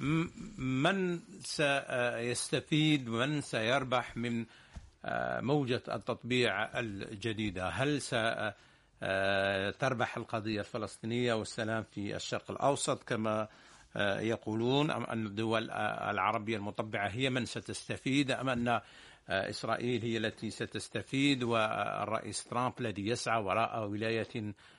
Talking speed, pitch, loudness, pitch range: 90 wpm, 115 Hz, -34 LUFS, 110-130 Hz